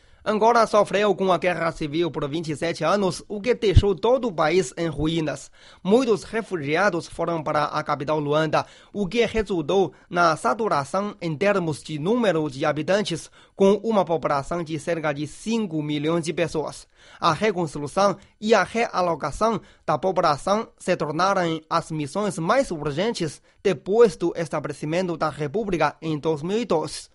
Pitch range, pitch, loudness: 155-205 Hz, 170 Hz, -23 LUFS